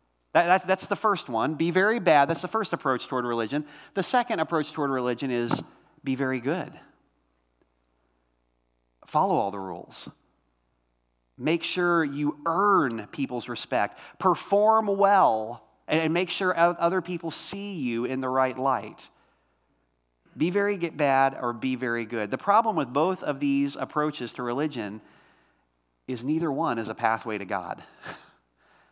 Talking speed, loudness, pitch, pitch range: 145 wpm, -26 LUFS, 135 Hz, 110-170 Hz